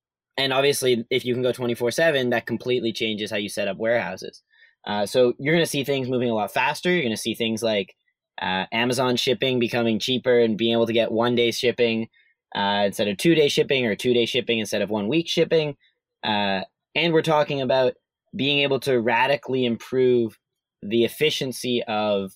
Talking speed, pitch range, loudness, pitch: 200 wpm, 115-135 Hz, -22 LUFS, 120 Hz